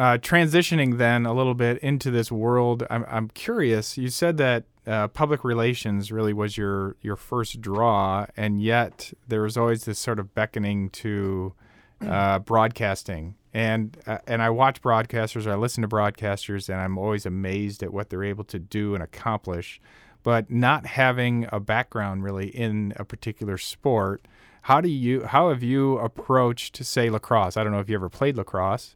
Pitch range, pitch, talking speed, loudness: 100-120 Hz, 110 Hz, 180 wpm, -24 LUFS